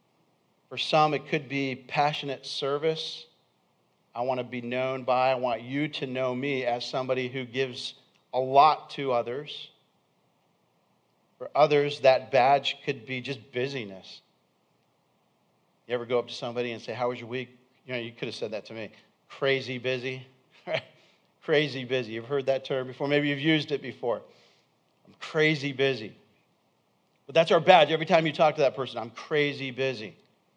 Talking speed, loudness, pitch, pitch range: 170 wpm, -27 LUFS, 135 Hz, 125-145 Hz